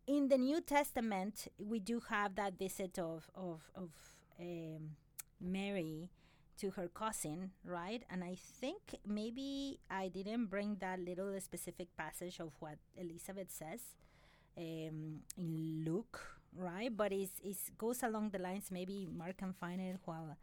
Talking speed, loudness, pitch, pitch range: 145 wpm, -43 LUFS, 185 Hz, 170-205 Hz